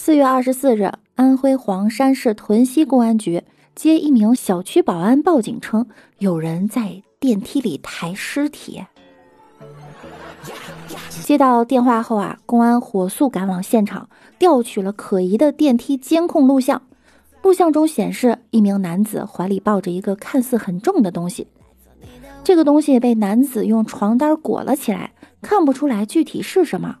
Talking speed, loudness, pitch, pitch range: 235 characters per minute, -17 LUFS, 240 Hz, 205-280 Hz